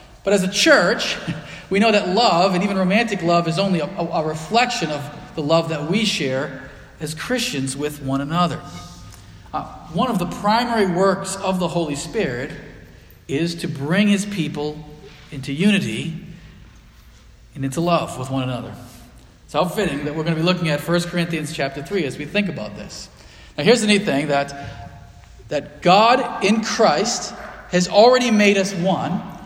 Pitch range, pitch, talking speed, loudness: 140-195 Hz, 170 Hz, 175 wpm, -19 LUFS